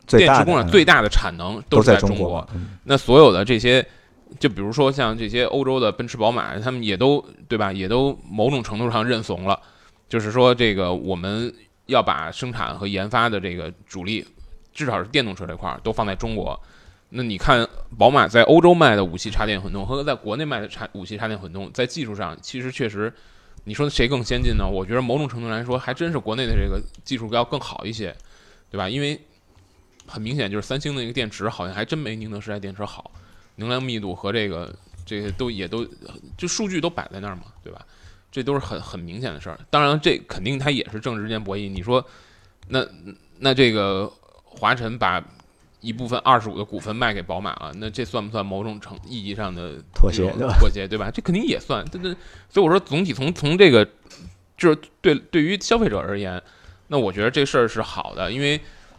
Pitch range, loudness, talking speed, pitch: 95-130 Hz, -21 LUFS, 310 characters per minute, 110 Hz